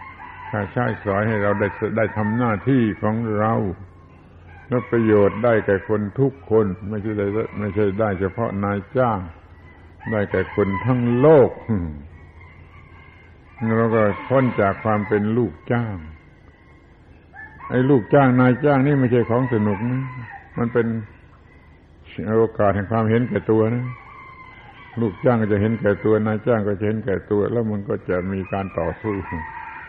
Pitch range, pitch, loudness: 95-115 Hz, 105 Hz, -20 LUFS